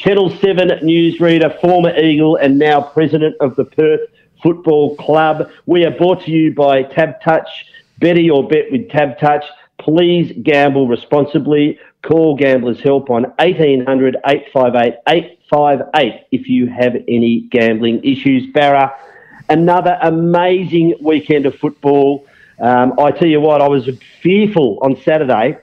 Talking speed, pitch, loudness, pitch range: 140 wpm, 150 Hz, -13 LUFS, 140-165 Hz